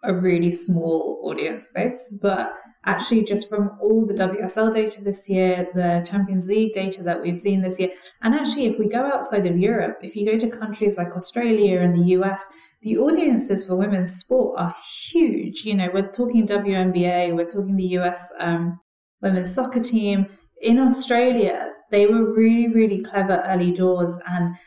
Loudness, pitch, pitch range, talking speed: -21 LUFS, 195 Hz, 180-220 Hz, 175 wpm